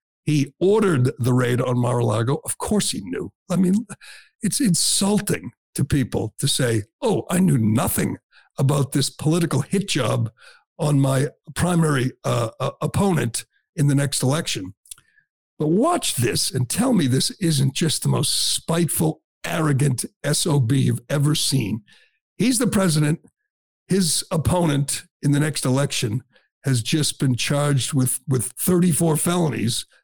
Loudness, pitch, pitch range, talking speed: -21 LUFS, 145 Hz, 130-170 Hz, 145 wpm